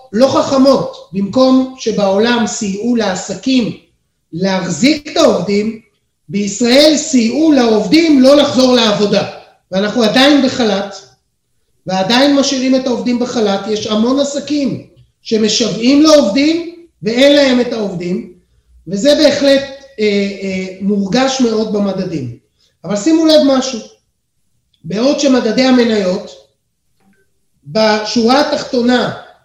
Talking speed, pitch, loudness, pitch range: 100 wpm, 230 Hz, -12 LUFS, 195-270 Hz